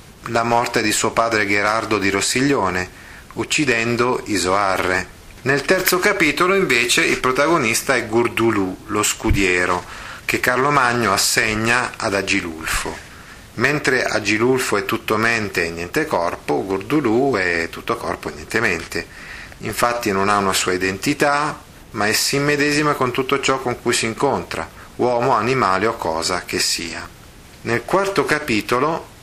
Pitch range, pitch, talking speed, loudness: 100-135 Hz, 115 Hz, 140 wpm, -18 LUFS